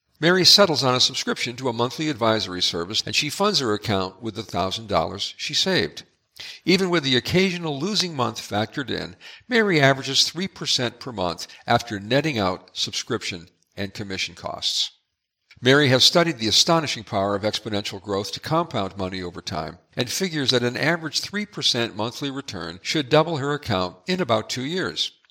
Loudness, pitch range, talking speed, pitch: -22 LUFS, 100-155 Hz, 165 wpm, 120 Hz